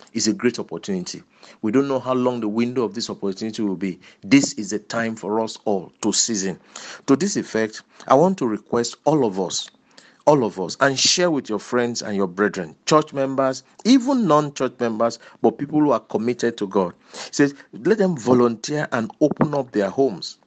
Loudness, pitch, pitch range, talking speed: -21 LUFS, 125 Hz, 110-145 Hz, 195 wpm